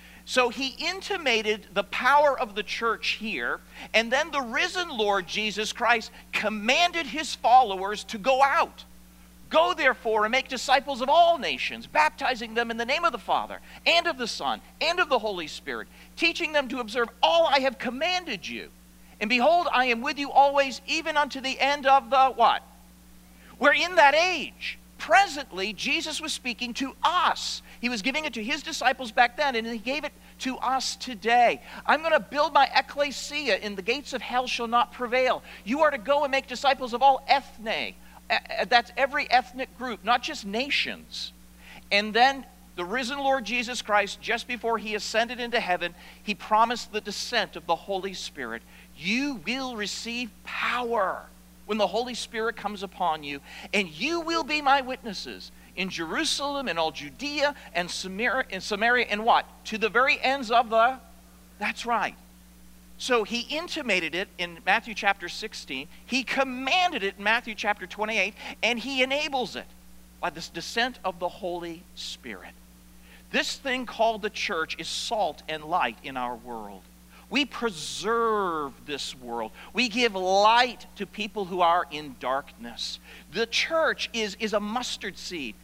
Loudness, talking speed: -26 LUFS, 170 wpm